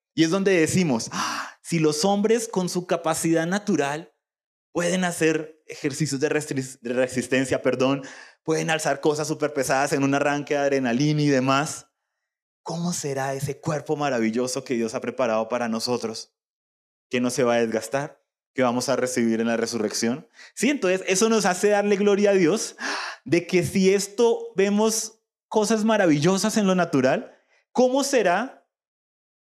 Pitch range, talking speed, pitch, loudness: 135-190 Hz, 155 wpm, 155 Hz, -23 LUFS